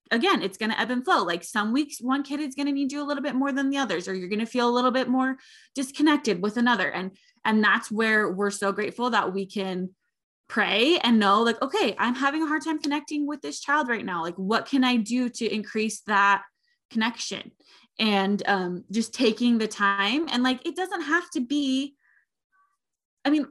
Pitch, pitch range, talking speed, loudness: 240 Hz, 210-285 Hz, 220 wpm, -25 LUFS